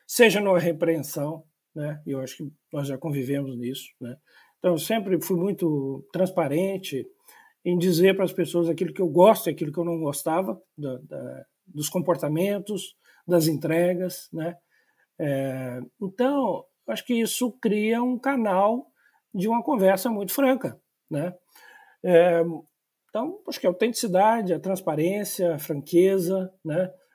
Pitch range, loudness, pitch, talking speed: 160-205 Hz, -25 LUFS, 180 Hz, 145 wpm